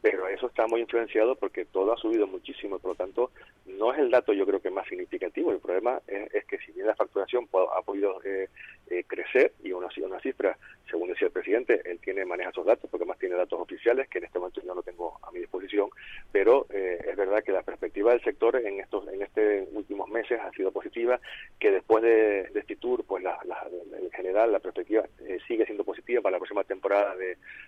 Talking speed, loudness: 230 wpm, -28 LUFS